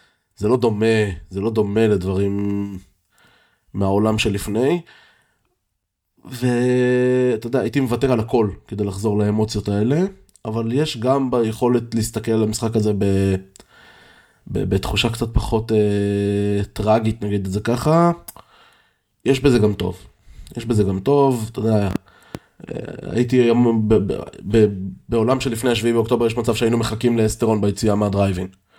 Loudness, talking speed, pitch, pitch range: -19 LUFS, 140 wpm, 110 Hz, 100-120 Hz